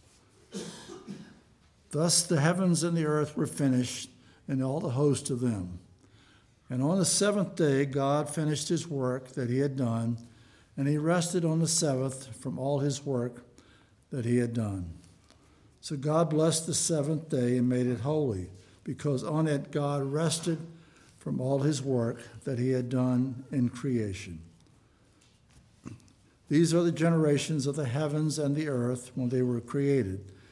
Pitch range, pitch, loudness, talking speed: 125-155 Hz, 135 Hz, -29 LUFS, 155 wpm